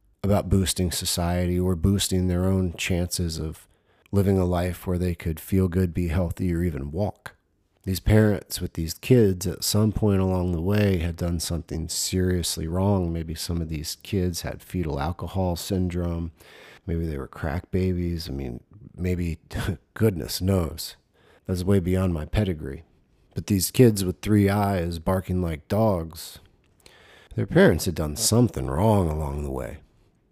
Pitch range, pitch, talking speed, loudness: 85-95 Hz, 90 Hz, 160 wpm, -25 LUFS